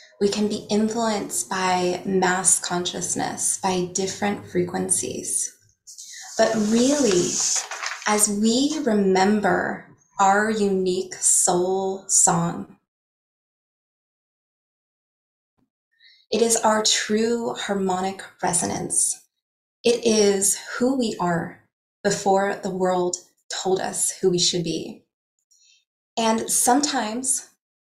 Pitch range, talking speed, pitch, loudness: 185-220 Hz, 90 wpm, 200 Hz, -21 LUFS